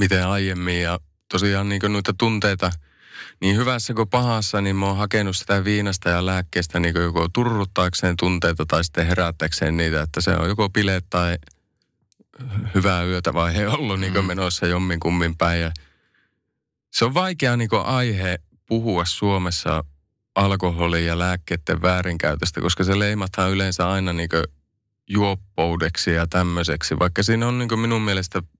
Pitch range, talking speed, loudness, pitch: 85-100 Hz, 155 wpm, -21 LUFS, 90 Hz